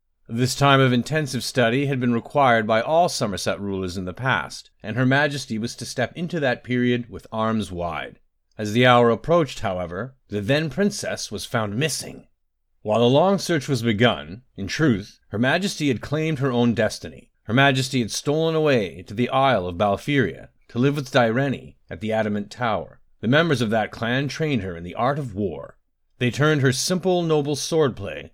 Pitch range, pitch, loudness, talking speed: 110-140 Hz, 125 Hz, -22 LUFS, 190 wpm